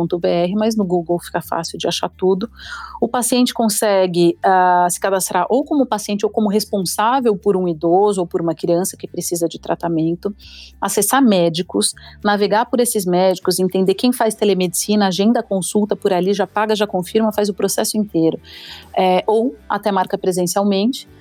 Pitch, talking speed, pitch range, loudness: 195 Hz, 165 wpm, 180-215 Hz, -17 LUFS